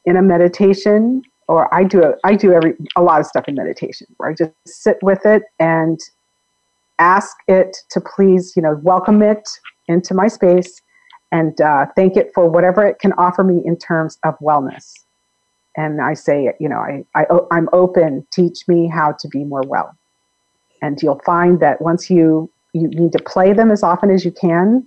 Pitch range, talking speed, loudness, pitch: 165-195 Hz, 195 wpm, -14 LUFS, 175 Hz